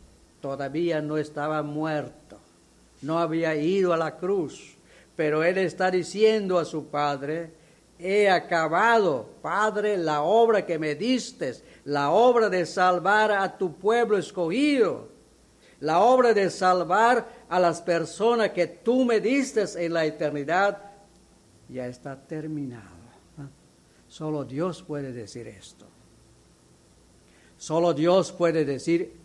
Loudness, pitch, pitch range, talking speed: -24 LUFS, 170 Hz, 145-200 Hz, 120 wpm